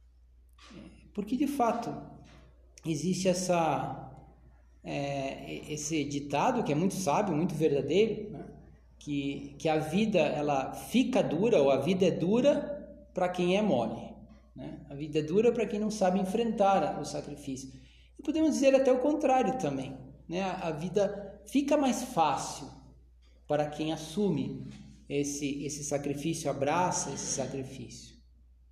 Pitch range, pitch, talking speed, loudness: 140-205 Hz, 155 Hz, 135 wpm, -30 LUFS